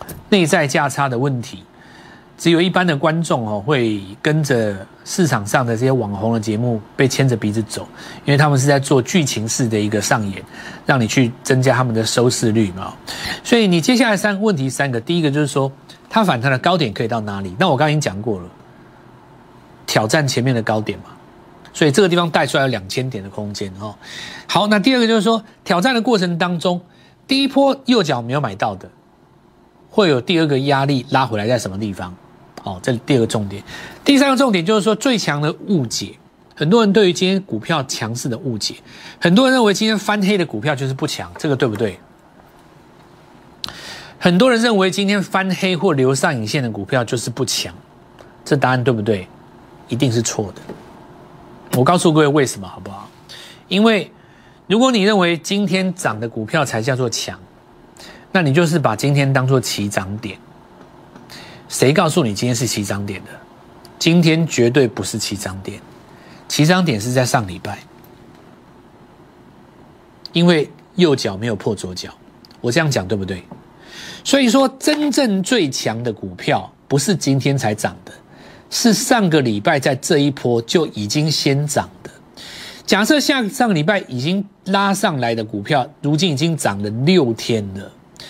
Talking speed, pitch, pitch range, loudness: 270 characters per minute, 140 Hz, 115-180 Hz, -17 LUFS